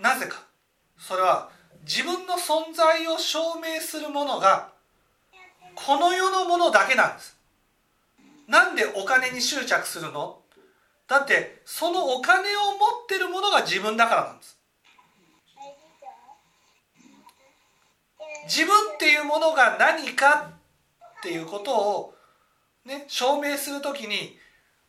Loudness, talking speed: -22 LUFS, 220 characters per minute